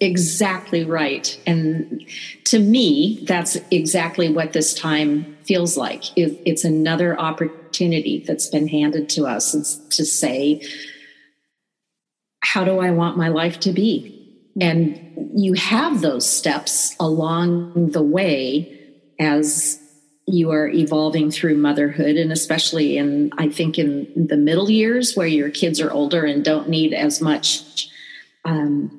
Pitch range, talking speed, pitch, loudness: 150-175 Hz, 130 wpm, 160 Hz, -19 LUFS